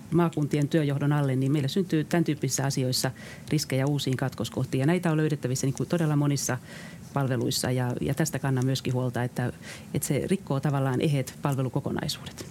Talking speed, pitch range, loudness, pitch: 145 wpm, 130-155 Hz, -27 LUFS, 140 Hz